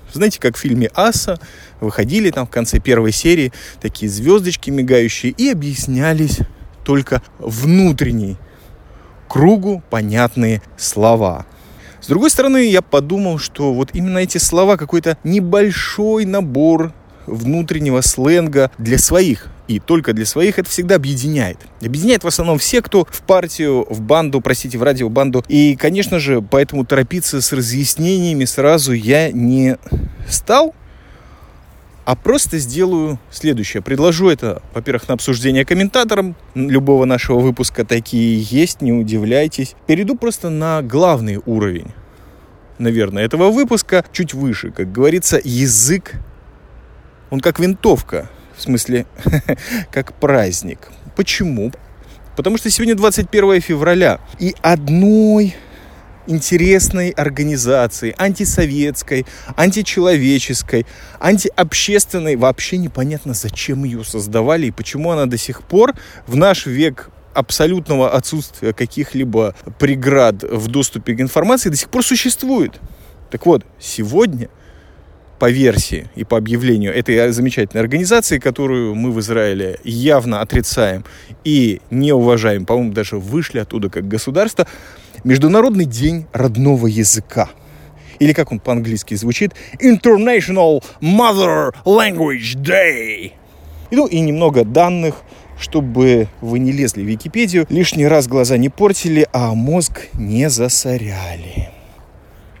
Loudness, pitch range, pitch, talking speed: -15 LUFS, 115-170 Hz, 135 Hz, 120 wpm